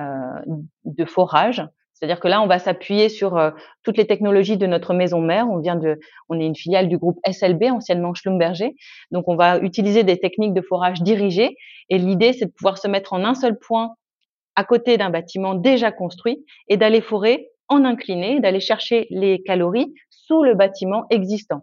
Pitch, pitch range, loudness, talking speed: 195 Hz, 180-225 Hz, -19 LUFS, 190 wpm